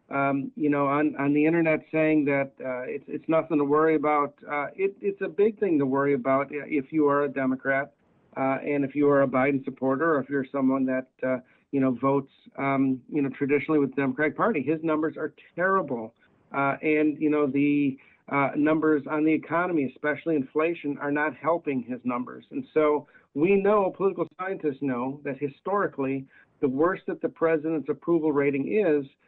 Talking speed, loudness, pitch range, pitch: 190 wpm, -26 LUFS, 135-155 Hz, 145 Hz